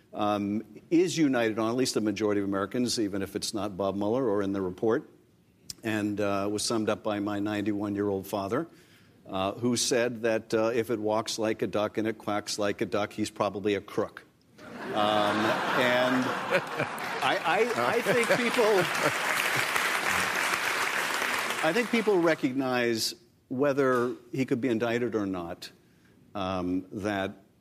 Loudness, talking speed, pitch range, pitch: -28 LUFS, 155 wpm, 100-120 Hz, 105 Hz